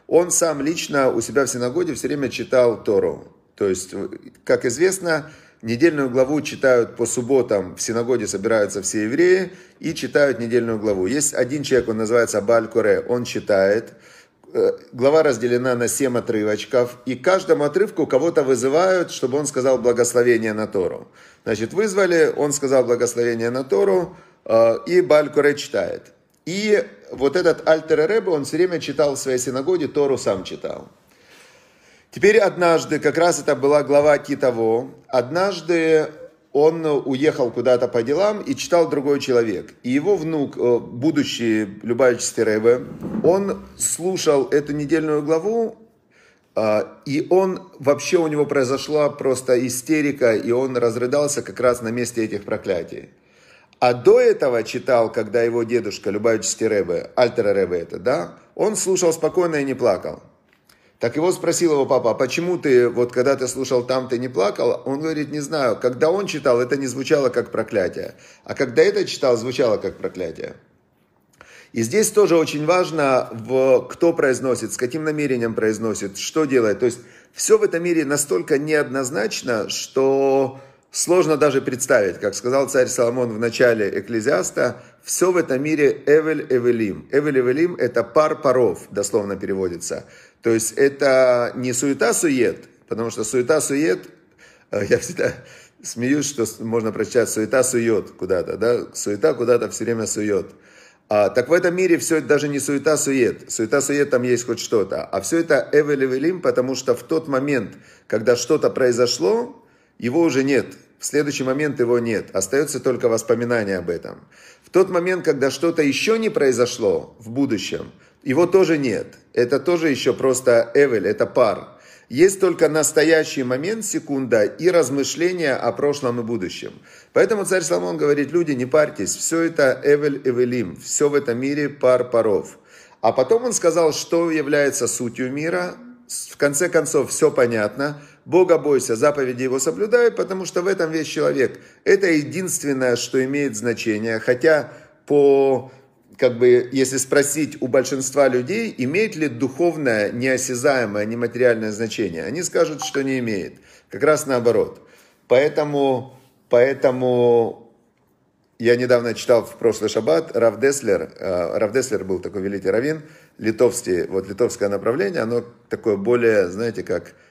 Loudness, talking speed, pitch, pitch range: -19 LUFS, 150 wpm, 140 Hz, 125-170 Hz